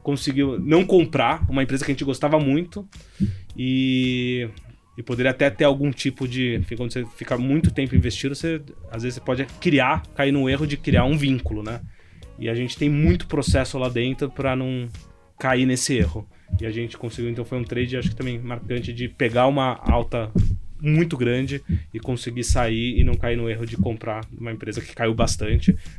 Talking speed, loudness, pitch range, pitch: 195 wpm, -23 LUFS, 115-135 Hz, 125 Hz